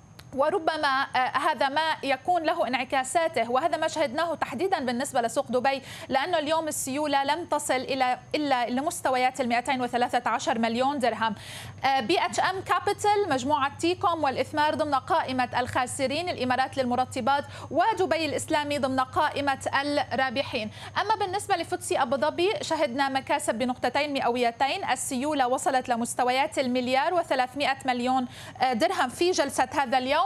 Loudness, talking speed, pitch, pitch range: -26 LUFS, 125 wpm, 275 Hz, 260-320 Hz